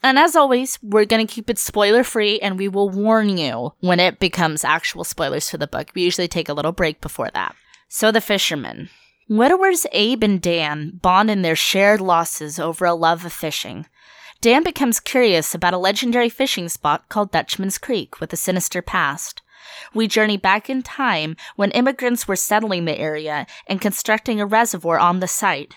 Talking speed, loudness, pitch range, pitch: 190 wpm, -18 LUFS, 170-225 Hz, 195 Hz